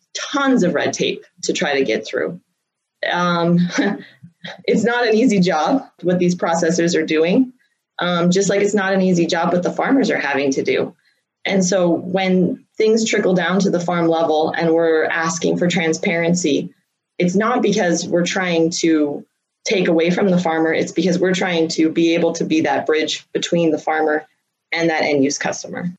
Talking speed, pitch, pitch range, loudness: 185 wpm, 175 Hz, 165-195 Hz, -18 LUFS